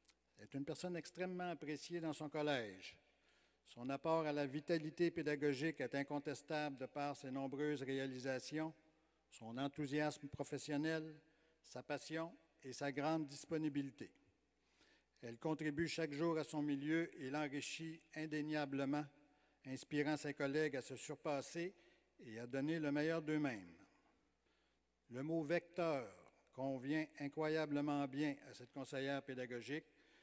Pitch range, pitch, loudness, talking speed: 140-160 Hz, 150 Hz, -44 LUFS, 125 wpm